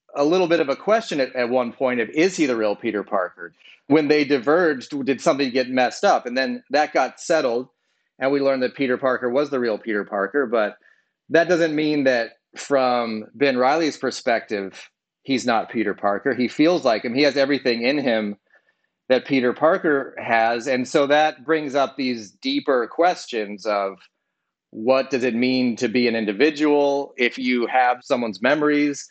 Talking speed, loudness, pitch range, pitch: 185 wpm, -21 LUFS, 120-145 Hz, 130 Hz